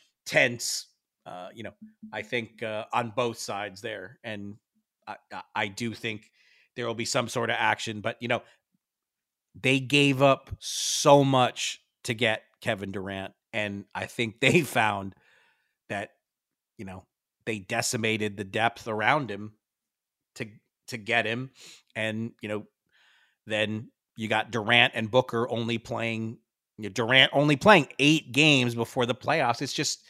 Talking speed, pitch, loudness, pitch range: 150 wpm, 115 Hz, -26 LUFS, 110-130 Hz